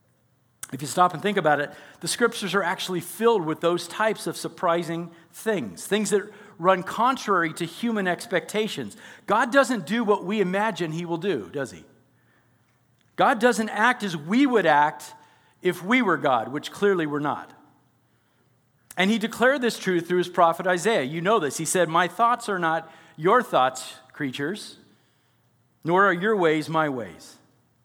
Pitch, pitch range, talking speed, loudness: 175 Hz, 145-210 Hz, 170 wpm, -24 LUFS